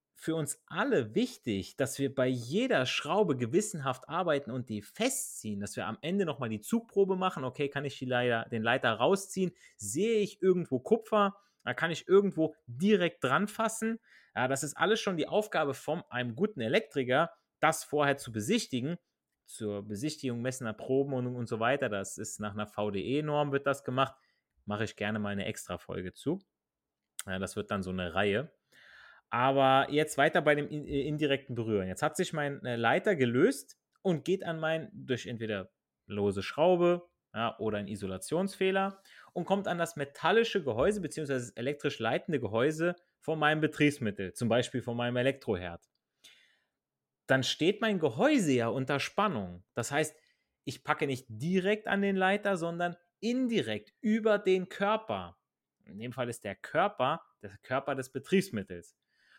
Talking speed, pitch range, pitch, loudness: 160 wpm, 115-175 Hz, 140 Hz, -31 LUFS